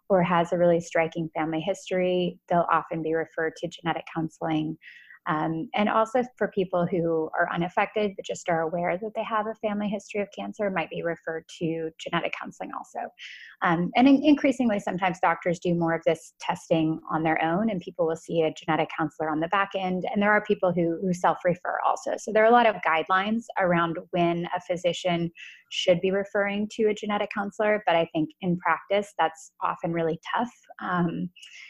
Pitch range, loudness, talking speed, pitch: 165-205 Hz, -26 LUFS, 195 wpm, 175 Hz